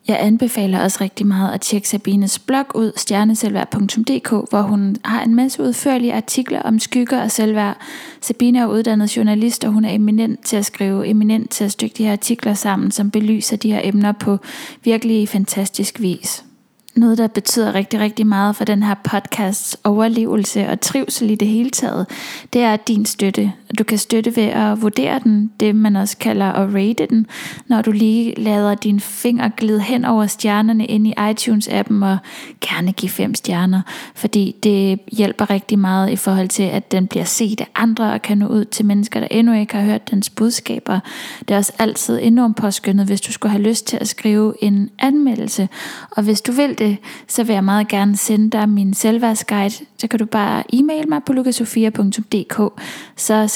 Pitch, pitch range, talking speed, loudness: 215 Hz, 205-230 Hz, 190 wpm, -17 LUFS